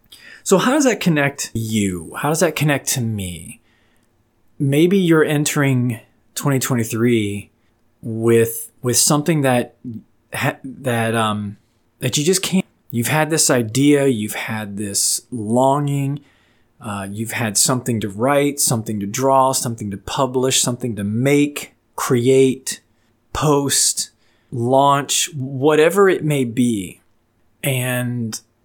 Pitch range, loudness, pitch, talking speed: 115-140 Hz, -18 LUFS, 125 Hz, 120 wpm